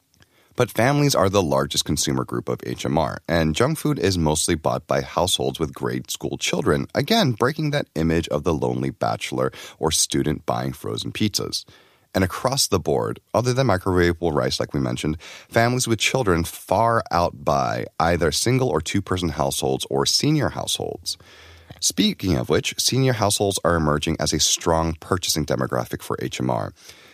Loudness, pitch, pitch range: -22 LUFS, 85 Hz, 70-110 Hz